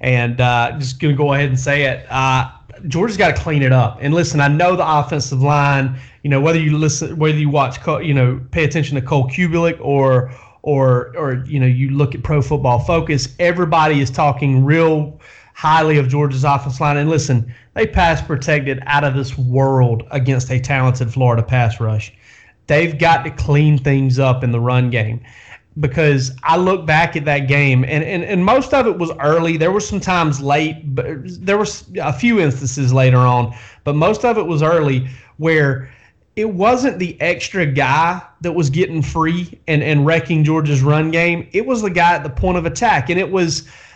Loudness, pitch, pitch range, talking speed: -16 LUFS, 145 Hz, 130-165 Hz, 200 wpm